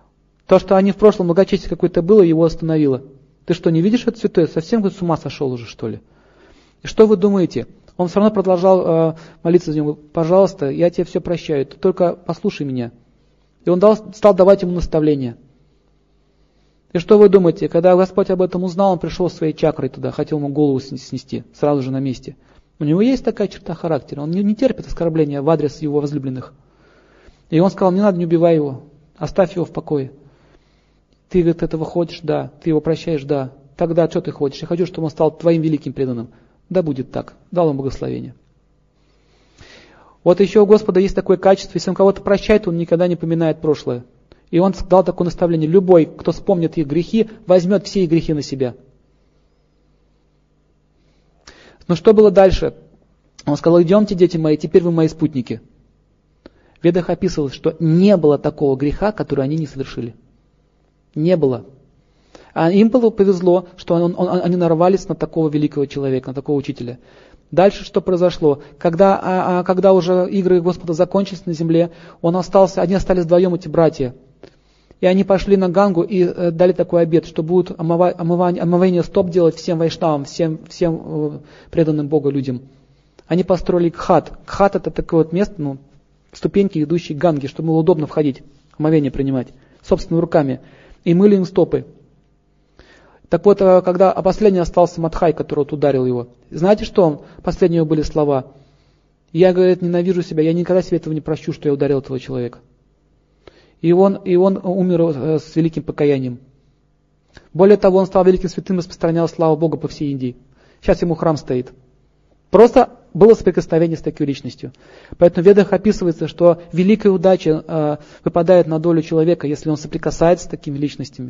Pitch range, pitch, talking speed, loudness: 145-185 Hz, 165 Hz, 175 wpm, -16 LUFS